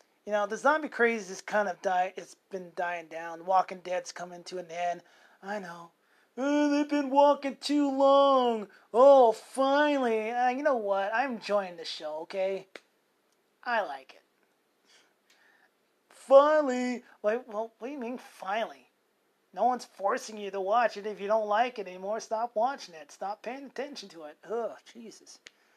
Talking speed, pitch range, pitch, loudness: 170 wpm, 190-265 Hz, 220 Hz, -28 LUFS